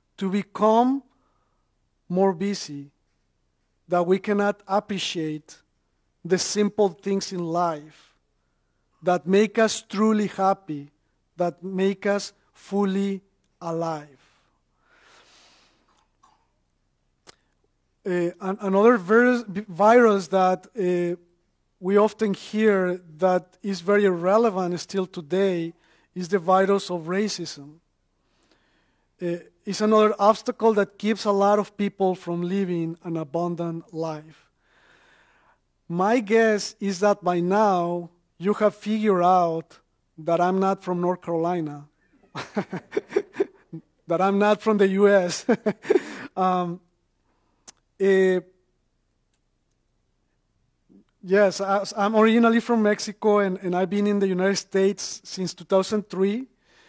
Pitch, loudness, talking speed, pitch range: 190 Hz, -23 LUFS, 100 wpm, 170-205 Hz